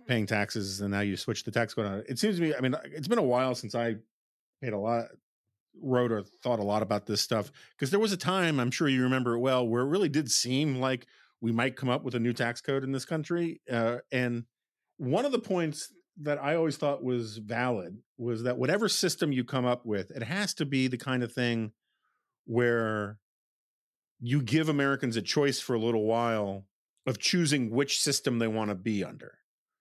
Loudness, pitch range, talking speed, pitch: -30 LUFS, 115-140 Hz, 220 wpm, 125 Hz